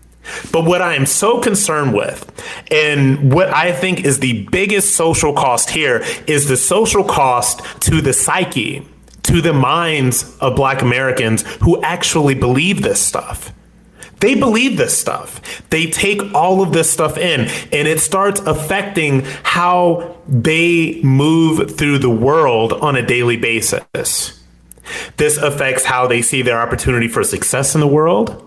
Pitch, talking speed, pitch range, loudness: 150 Hz, 150 wpm, 130-170 Hz, -14 LUFS